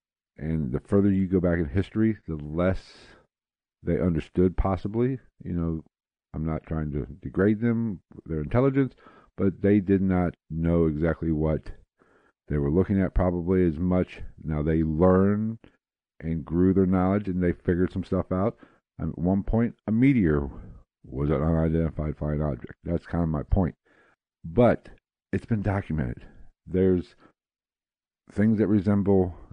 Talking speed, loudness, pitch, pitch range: 150 wpm, -26 LUFS, 90 Hz, 80-100 Hz